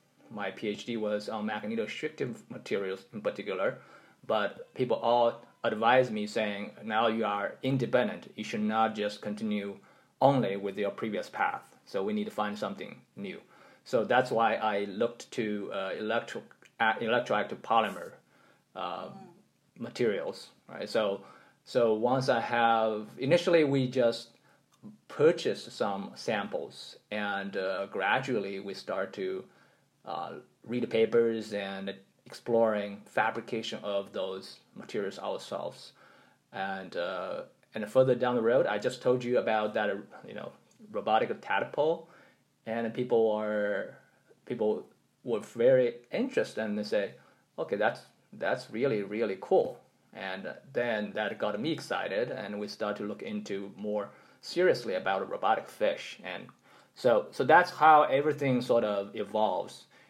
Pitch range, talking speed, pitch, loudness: 105-125 Hz, 140 wpm, 110 Hz, -30 LUFS